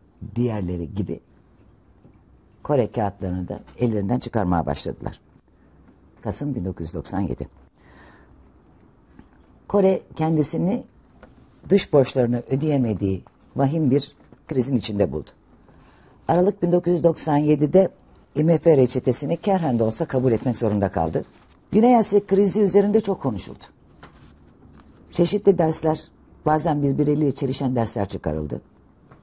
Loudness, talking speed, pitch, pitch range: -22 LUFS, 90 wpm, 130 Hz, 95-160 Hz